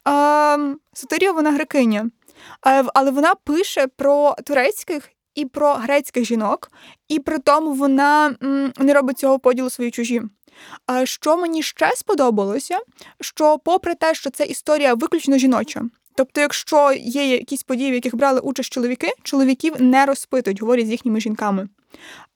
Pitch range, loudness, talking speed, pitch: 255-300 Hz, -18 LUFS, 140 wpm, 275 Hz